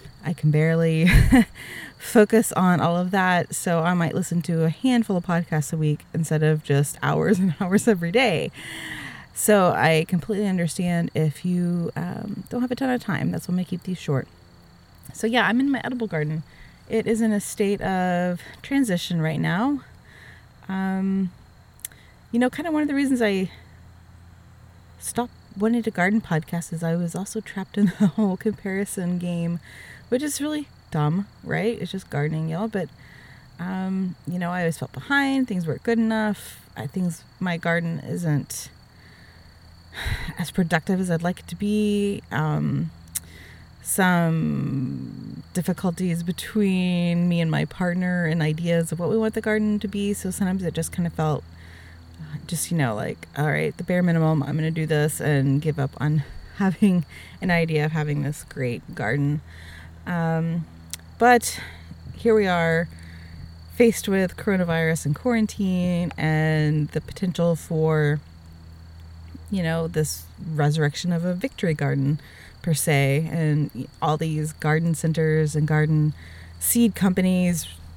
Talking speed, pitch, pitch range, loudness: 160 wpm, 170 Hz, 150-190 Hz, -23 LUFS